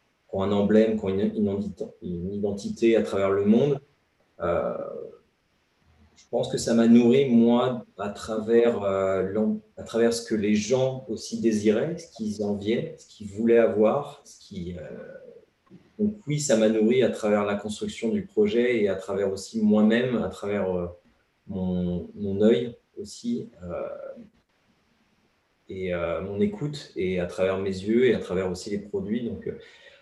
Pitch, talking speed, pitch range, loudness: 110 Hz, 160 wpm, 100-145 Hz, -25 LUFS